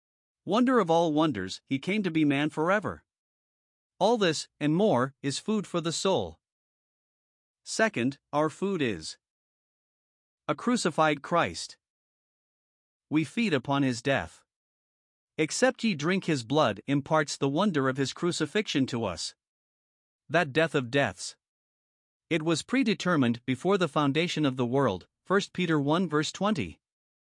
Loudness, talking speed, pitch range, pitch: -28 LUFS, 135 wpm, 135-180 Hz, 155 Hz